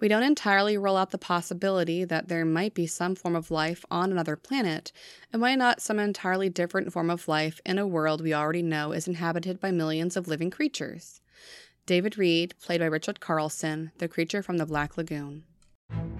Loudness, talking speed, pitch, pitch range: -28 LUFS, 195 wpm, 175 Hz, 160-195 Hz